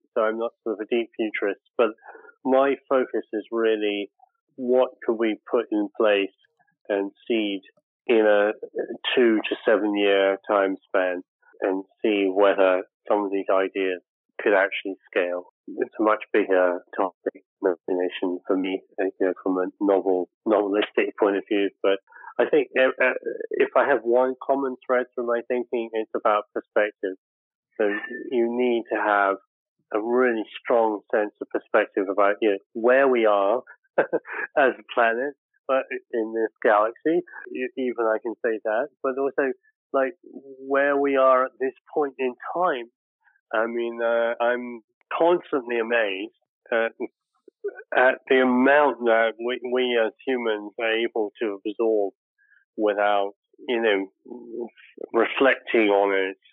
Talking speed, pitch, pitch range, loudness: 145 wpm, 115 Hz, 100-135 Hz, -24 LUFS